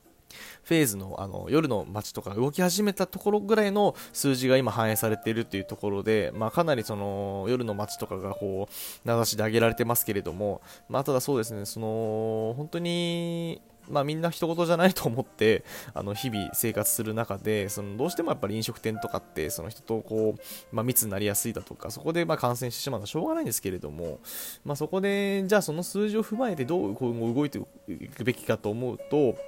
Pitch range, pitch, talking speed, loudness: 105-155 Hz, 115 Hz, 420 characters per minute, -28 LUFS